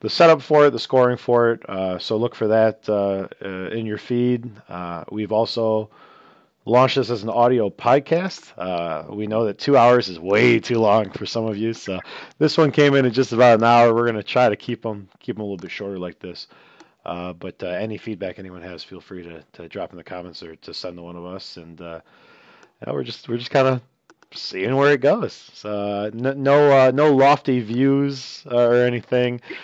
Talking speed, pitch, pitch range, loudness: 220 wpm, 115 Hz, 100-125 Hz, -19 LUFS